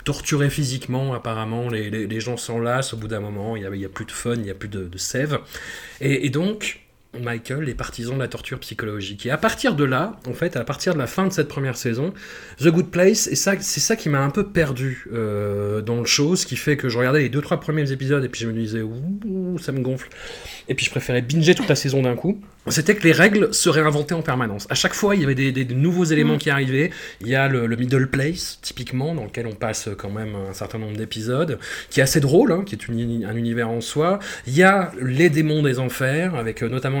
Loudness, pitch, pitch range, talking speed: -21 LUFS, 130 Hz, 115-160 Hz, 260 wpm